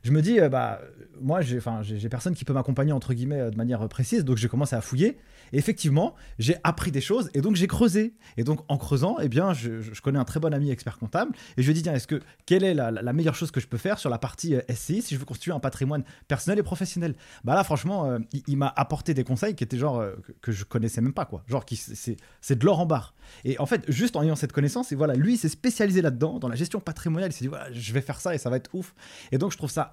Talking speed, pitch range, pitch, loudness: 300 wpm, 125-170 Hz, 140 Hz, -27 LUFS